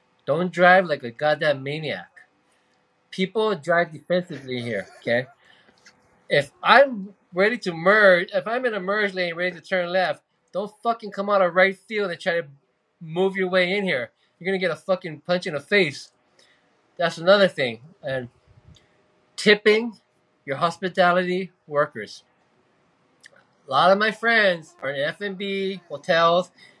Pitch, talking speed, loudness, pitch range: 185 Hz, 150 wpm, -22 LUFS, 160-195 Hz